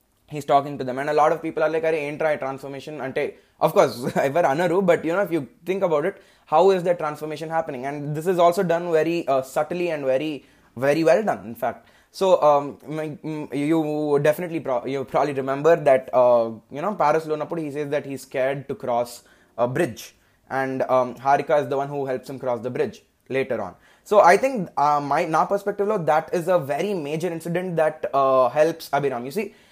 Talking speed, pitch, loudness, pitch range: 210 wpm, 150 Hz, -22 LUFS, 135-165 Hz